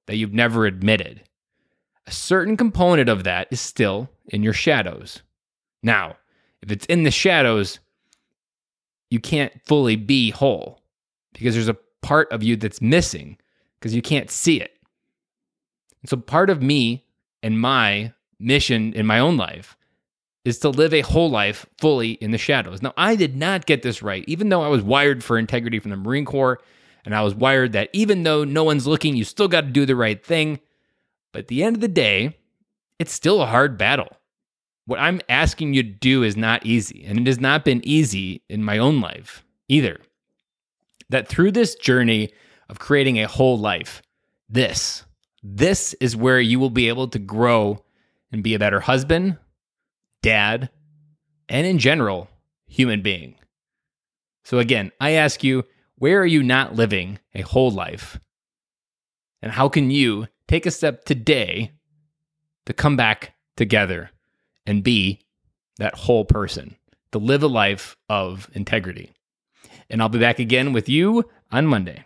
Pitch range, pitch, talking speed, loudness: 110-150 Hz, 125 Hz, 170 wpm, -19 LUFS